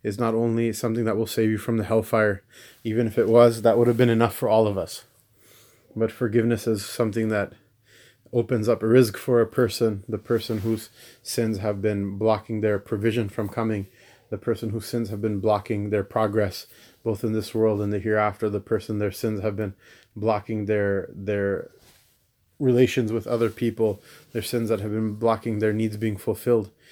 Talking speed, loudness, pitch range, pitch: 190 wpm, -24 LUFS, 105-115 Hz, 110 Hz